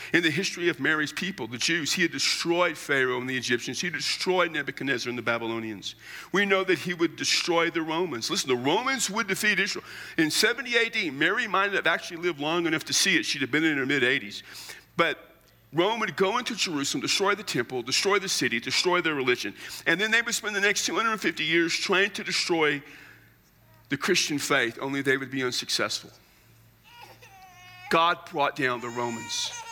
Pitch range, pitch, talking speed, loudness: 135-190 Hz, 165 Hz, 190 wpm, -25 LUFS